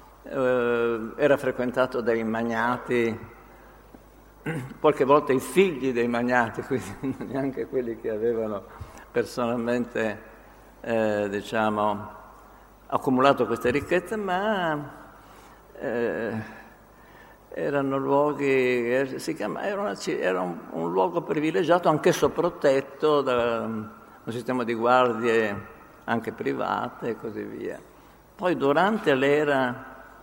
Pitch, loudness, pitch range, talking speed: 125 Hz, -25 LUFS, 115-140 Hz, 100 wpm